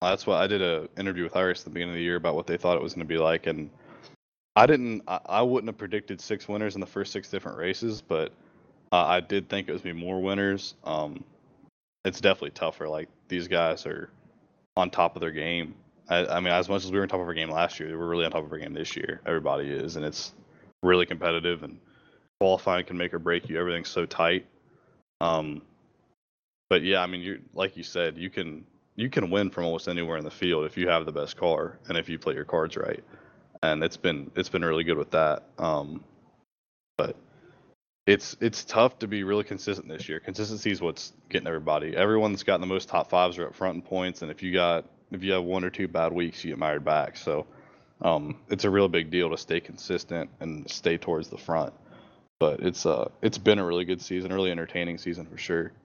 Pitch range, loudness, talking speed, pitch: 85-100 Hz, -28 LUFS, 235 wpm, 90 Hz